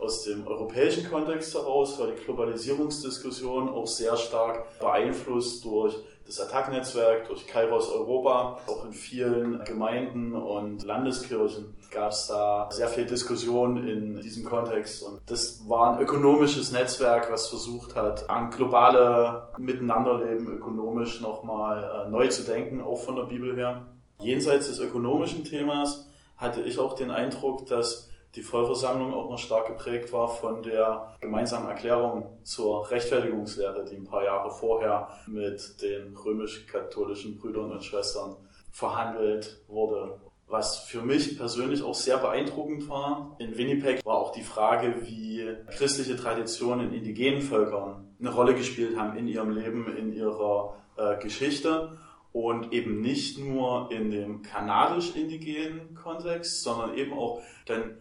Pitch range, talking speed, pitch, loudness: 110-135 Hz, 140 wpm, 120 Hz, -29 LUFS